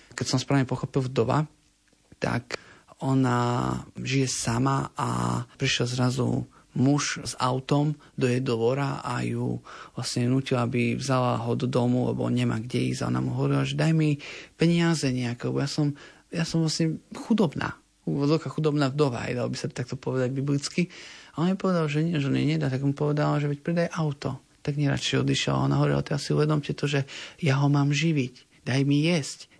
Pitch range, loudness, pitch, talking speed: 125-150 Hz, -26 LUFS, 135 Hz, 185 wpm